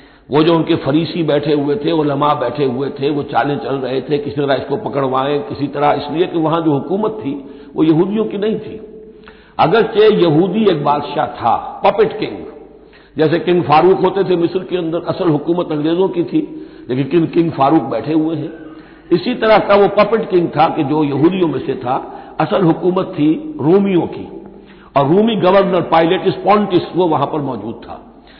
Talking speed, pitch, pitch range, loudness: 190 wpm, 165 Hz, 145-195 Hz, -15 LUFS